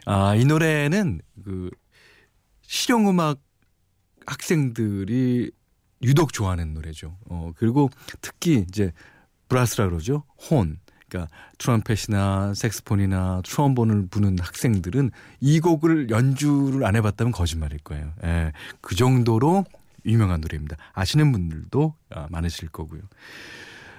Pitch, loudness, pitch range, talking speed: 110 Hz, -23 LUFS, 90-135 Hz, 265 characters per minute